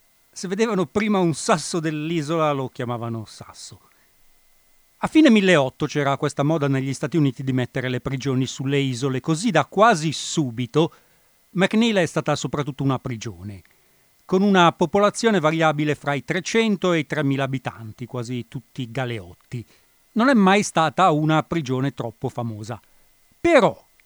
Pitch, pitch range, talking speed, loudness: 150 Hz, 130-175 Hz, 140 wpm, -21 LUFS